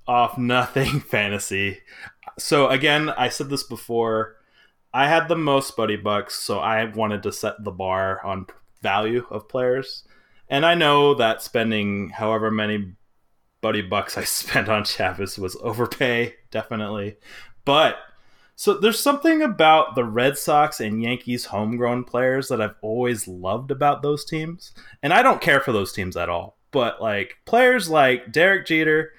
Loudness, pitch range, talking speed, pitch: -21 LUFS, 105-145 Hz, 155 wpm, 120 Hz